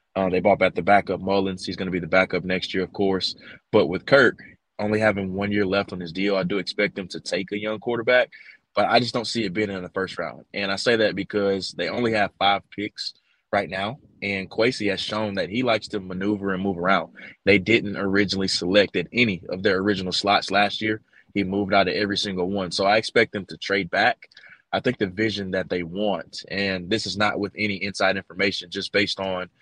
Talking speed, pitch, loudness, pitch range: 235 wpm, 100 Hz, -23 LUFS, 95-105 Hz